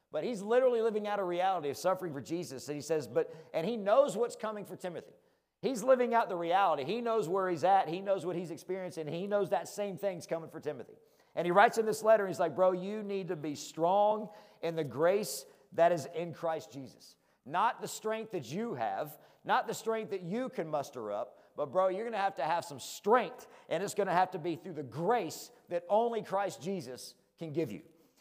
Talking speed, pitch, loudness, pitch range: 230 wpm, 185 Hz, -33 LUFS, 165-215 Hz